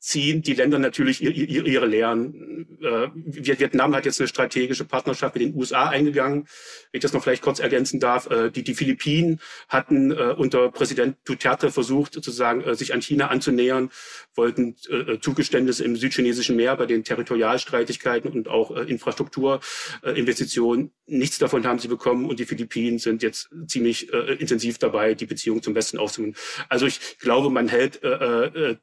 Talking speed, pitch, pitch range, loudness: 175 wpm, 130 Hz, 120-150 Hz, -23 LUFS